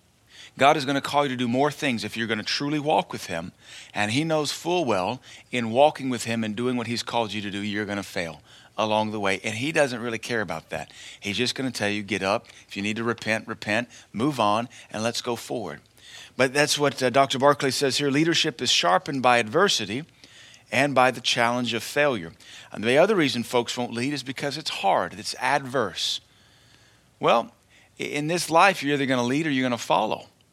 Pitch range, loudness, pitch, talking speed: 110-145 Hz, -24 LUFS, 125 Hz, 225 wpm